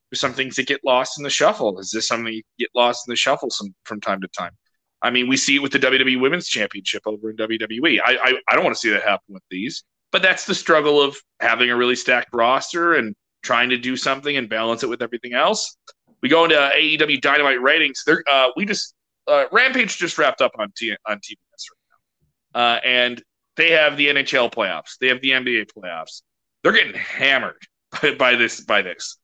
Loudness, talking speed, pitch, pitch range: -18 LUFS, 220 wpm, 130 Hz, 120-140 Hz